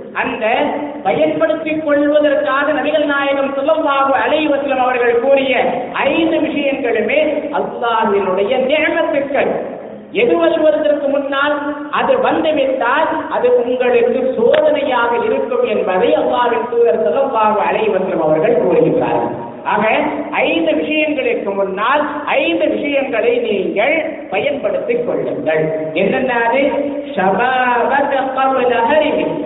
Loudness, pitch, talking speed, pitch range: -15 LUFS, 275 Hz, 80 wpm, 235-300 Hz